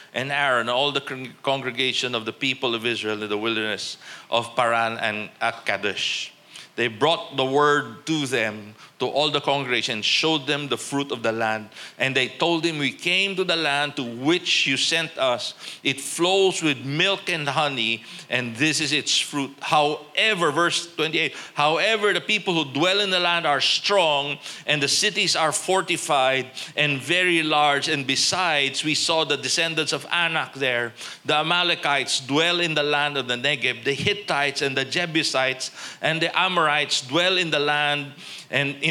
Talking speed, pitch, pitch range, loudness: 175 wpm, 145 Hz, 130-165 Hz, -22 LUFS